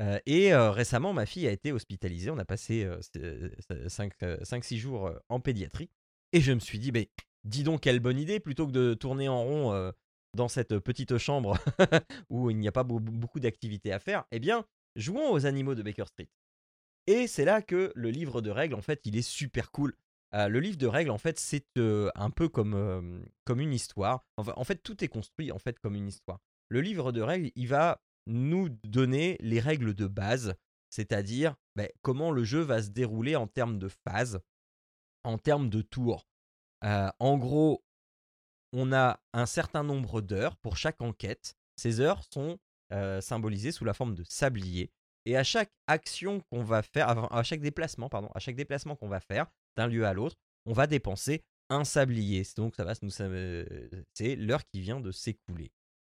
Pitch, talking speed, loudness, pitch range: 115 Hz, 190 wpm, -31 LUFS, 100-140 Hz